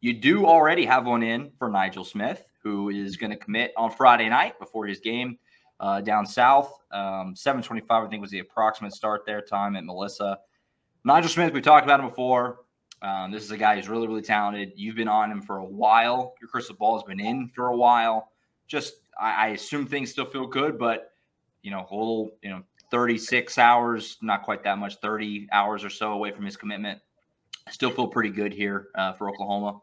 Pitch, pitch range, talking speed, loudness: 110 Hz, 100-125 Hz, 210 wpm, -24 LUFS